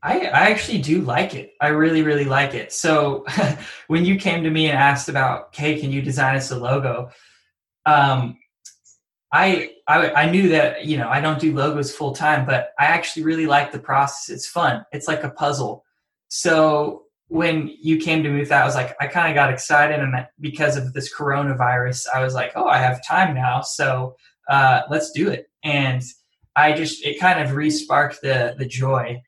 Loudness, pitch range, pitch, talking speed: -19 LUFS, 135-155 Hz, 145 Hz, 205 wpm